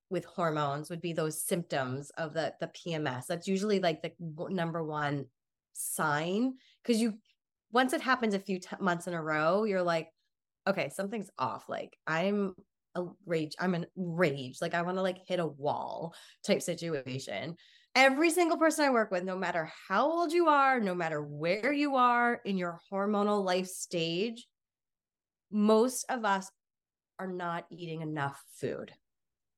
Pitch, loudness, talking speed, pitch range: 180 Hz, -31 LUFS, 165 wpm, 165-210 Hz